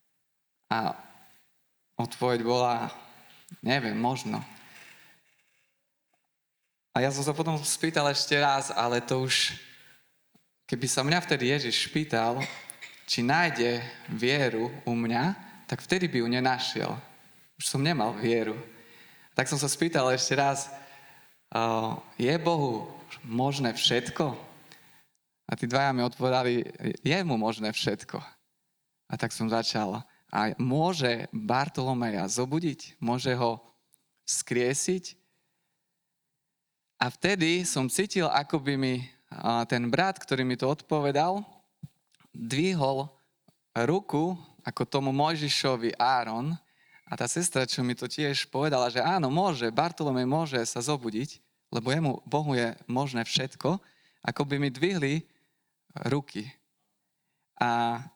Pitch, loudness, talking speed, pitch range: 135 Hz, -28 LUFS, 115 wpm, 120-160 Hz